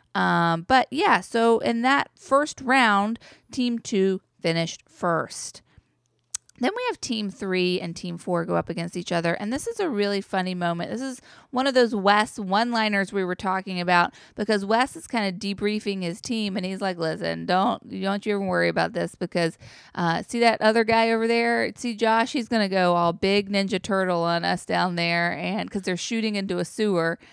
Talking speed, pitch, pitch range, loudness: 200 wpm, 200 Hz, 180-230 Hz, -24 LUFS